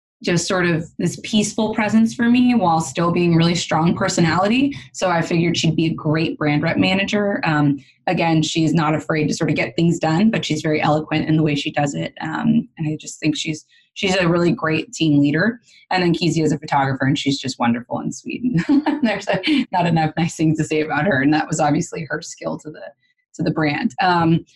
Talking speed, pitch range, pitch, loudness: 220 wpm, 155-190 Hz, 165 Hz, -19 LUFS